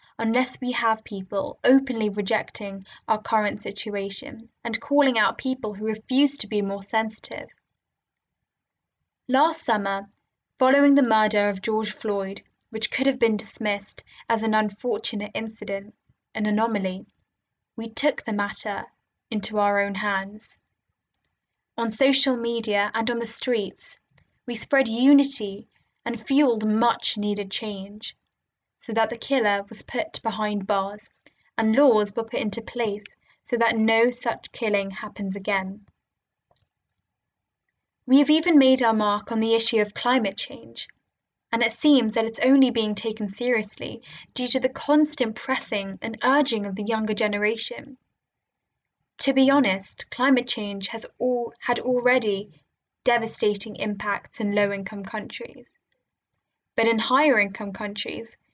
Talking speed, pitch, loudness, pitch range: 135 wpm, 225 Hz, -24 LUFS, 205-245 Hz